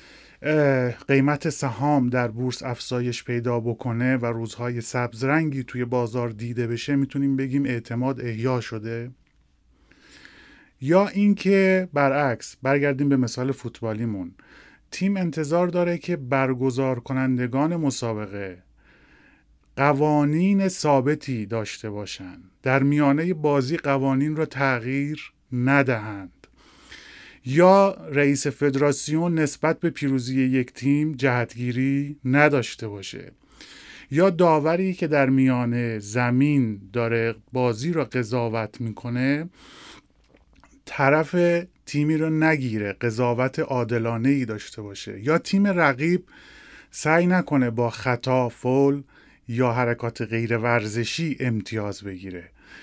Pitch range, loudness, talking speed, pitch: 120-150 Hz, -23 LUFS, 100 wpm, 130 Hz